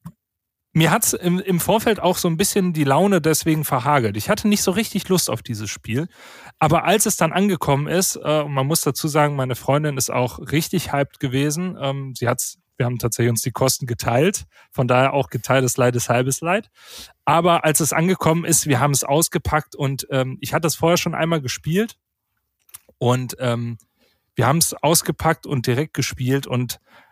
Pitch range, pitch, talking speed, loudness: 130-170 Hz, 145 Hz, 195 wpm, -20 LUFS